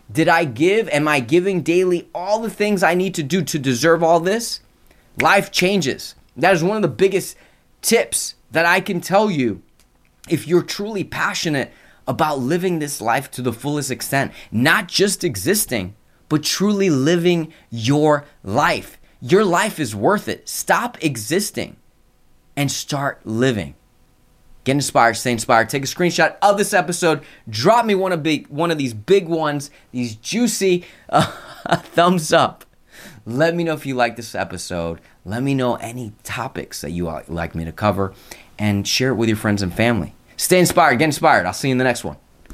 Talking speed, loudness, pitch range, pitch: 175 wpm, -19 LUFS, 115-175 Hz, 145 Hz